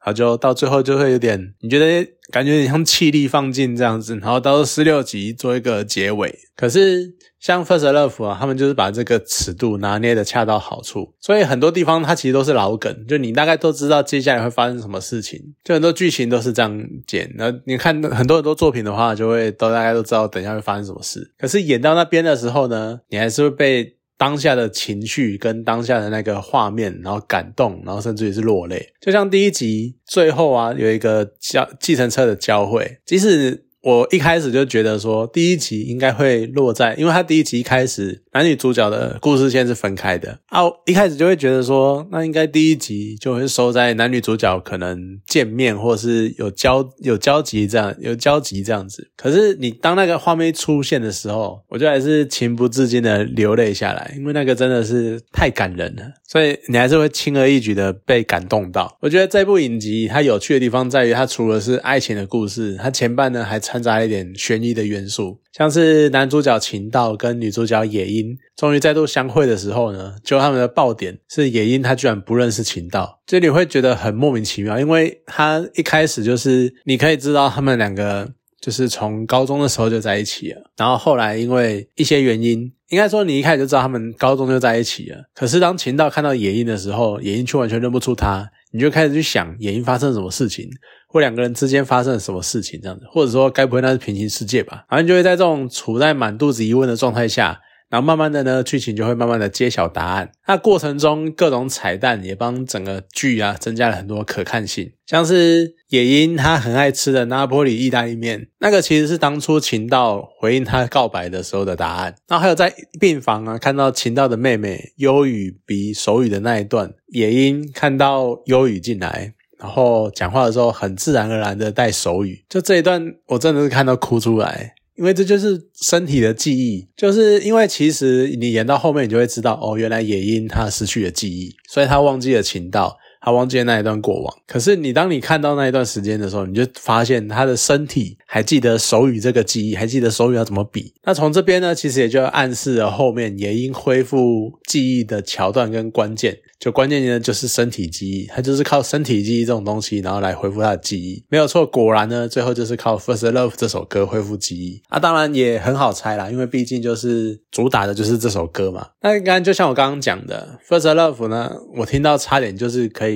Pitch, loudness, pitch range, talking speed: 125 Hz, -17 LUFS, 110-145 Hz, 340 characters per minute